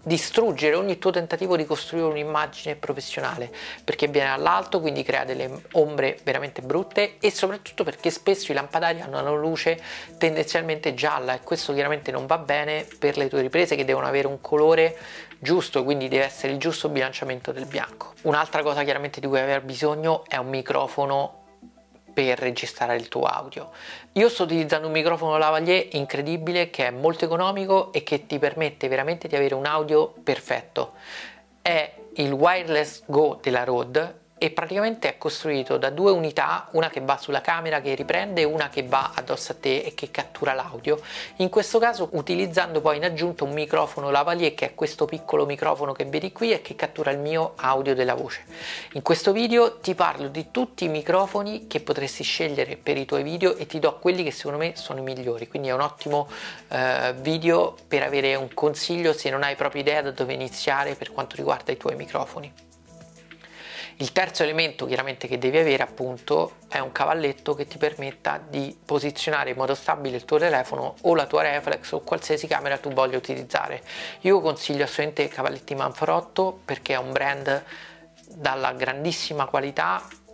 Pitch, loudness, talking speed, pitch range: 150 Hz, -24 LUFS, 180 wpm, 140-170 Hz